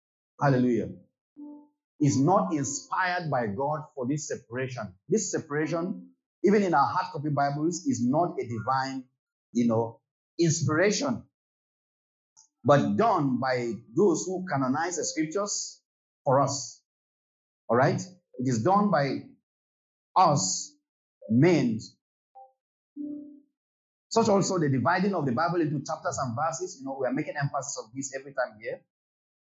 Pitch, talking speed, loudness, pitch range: 155 Hz, 130 wpm, -27 LUFS, 135-200 Hz